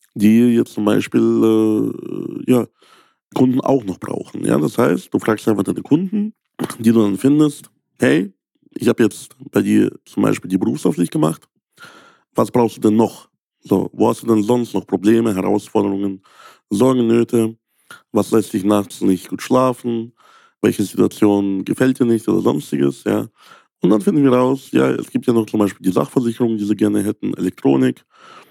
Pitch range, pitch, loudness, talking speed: 100-120 Hz, 110 Hz, -17 LUFS, 175 wpm